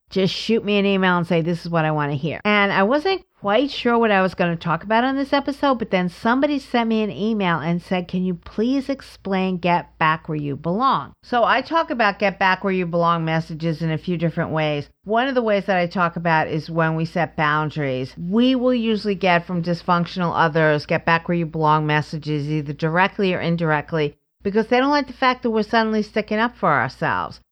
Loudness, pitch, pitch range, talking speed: -20 LUFS, 180 Hz, 165-220 Hz, 230 wpm